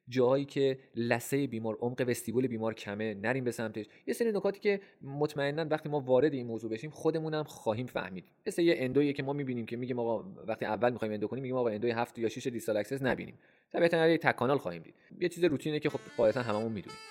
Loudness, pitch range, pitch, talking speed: -32 LUFS, 115-150 Hz, 130 Hz, 220 wpm